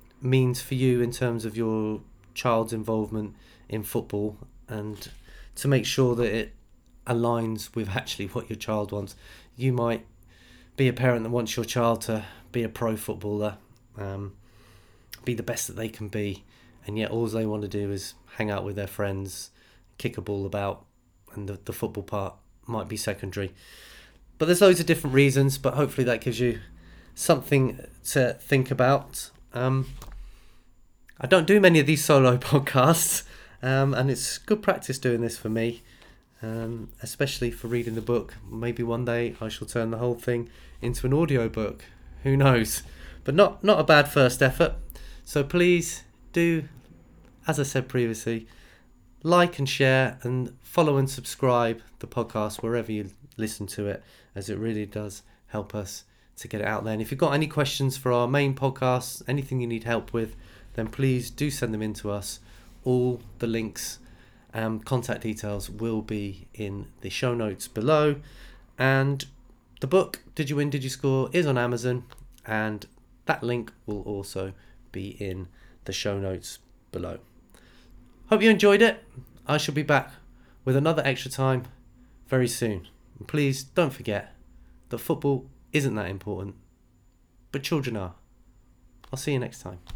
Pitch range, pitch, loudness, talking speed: 105-130 Hz, 120 Hz, -26 LUFS, 170 wpm